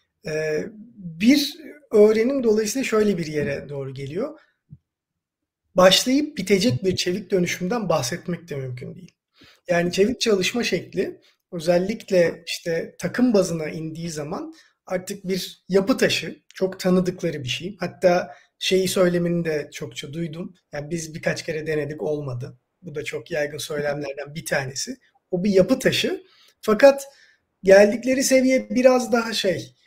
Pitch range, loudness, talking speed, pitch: 160-220 Hz, -22 LUFS, 130 wpm, 185 Hz